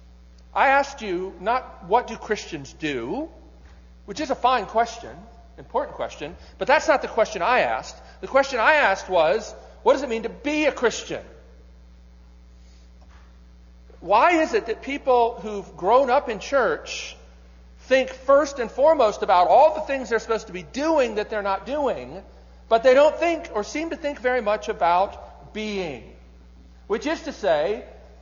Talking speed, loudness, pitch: 165 wpm, -22 LUFS, 215 Hz